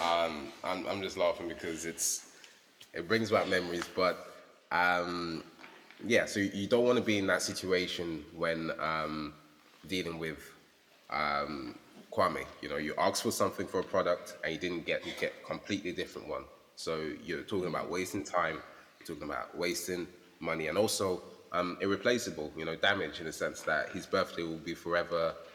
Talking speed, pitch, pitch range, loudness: 175 wpm, 85 Hz, 80-90 Hz, -34 LUFS